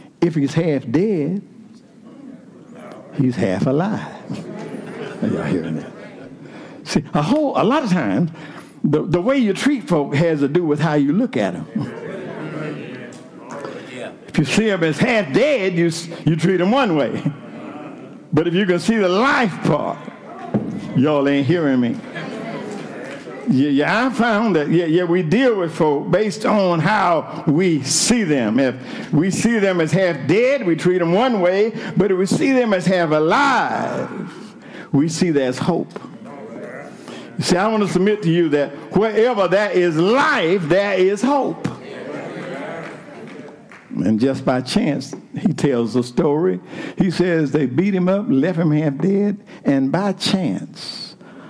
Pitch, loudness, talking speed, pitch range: 185 Hz, -18 LUFS, 155 wpm, 160-215 Hz